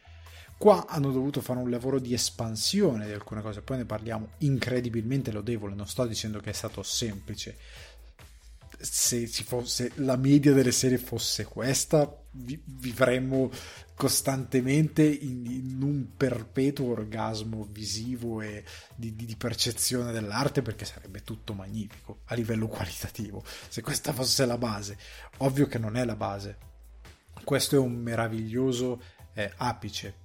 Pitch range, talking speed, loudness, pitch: 105-130 Hz, 140 wpm, -29 LUFS, 120 Hz